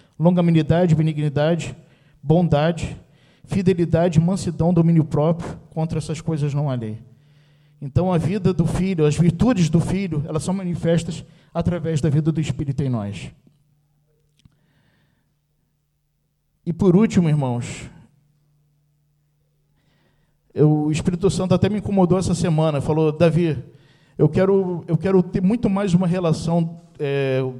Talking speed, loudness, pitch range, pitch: 125 wpm, -20 LUFS, 150-175 Hz, 155 Hz